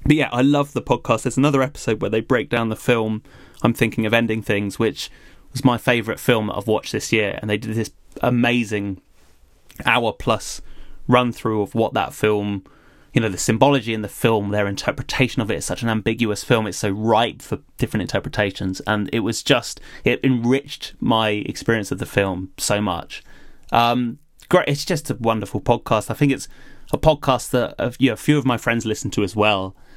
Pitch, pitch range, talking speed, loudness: 115 Hz, 105-125 Hz, 195 wpm, -20 LUFS